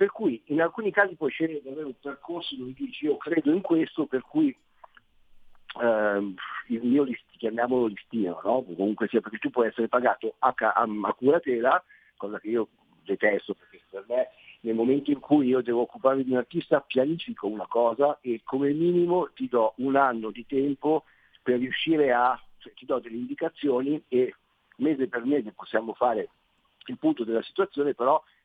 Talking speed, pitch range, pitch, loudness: 175 wpm, 120-170 Hz, 140 Hz, -27 LUFS